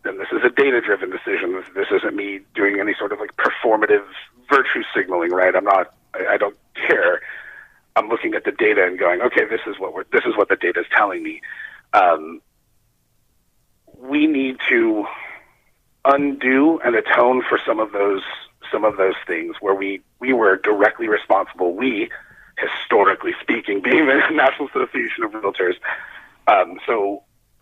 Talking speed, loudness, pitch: 165 wpm, -19 LUFS, 370 Hz